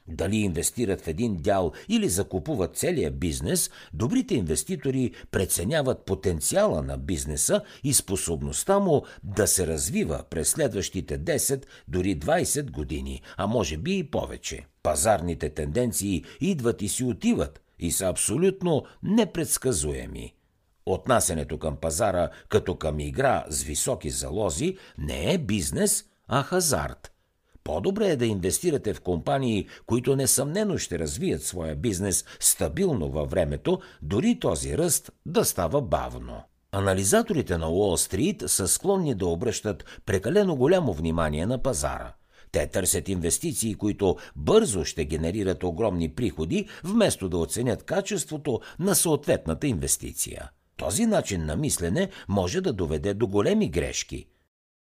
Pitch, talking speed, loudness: 100 Hz, 125 wpm, -26 LUFS